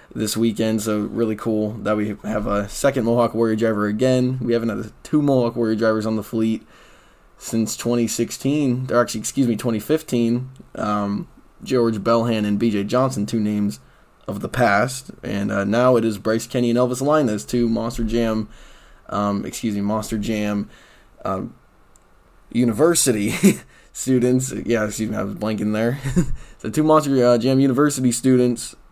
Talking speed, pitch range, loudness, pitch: 160 wpm, 105-125 Hz, -20 LUFS, 115 Hz